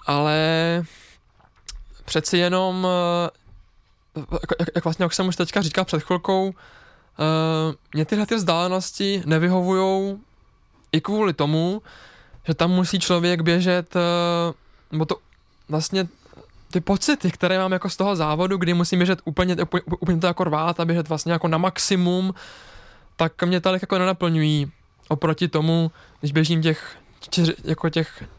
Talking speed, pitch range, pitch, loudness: 130 wpm, 160-185 Hz, 175 Hz, -22 LUFS